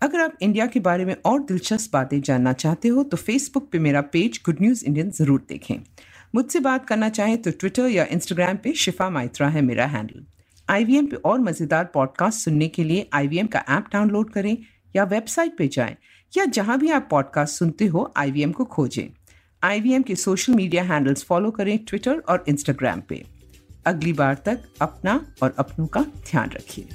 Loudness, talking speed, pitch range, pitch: -22 LUFS, 190 wpm, 145-220 Hz, 180 Hz